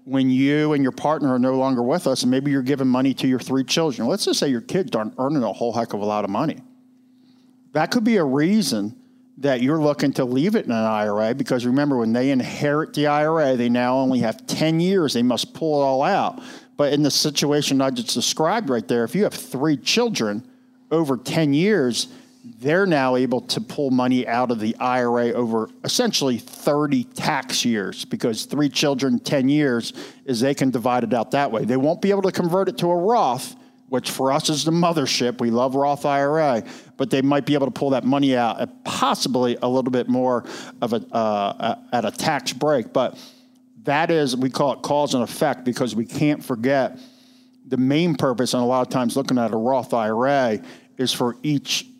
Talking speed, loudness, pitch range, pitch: 210 wpm, -21 LUFS, 125-165 Hz, 140 Hz